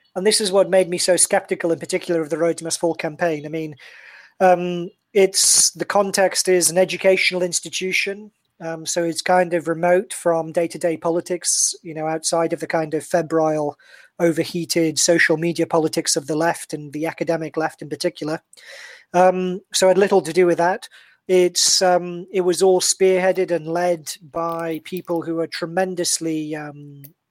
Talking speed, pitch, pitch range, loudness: 170 wpm, 170 Hz, 165-185 Hz, -19 LUFS